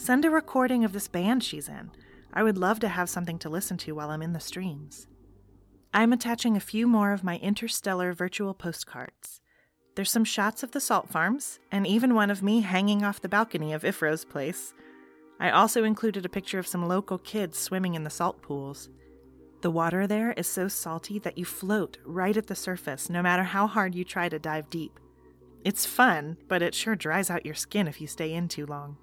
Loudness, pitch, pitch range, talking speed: -28 LUFS, 185 Hz, 160-210 Hz, 210 wpm